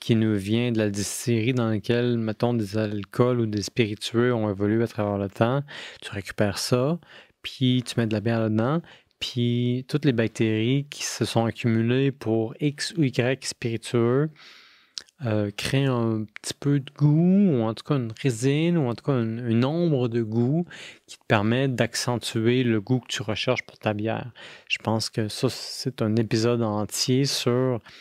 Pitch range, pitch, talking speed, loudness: 110-130 Hz, 120 Hz, 180 wpm, -25 LUFS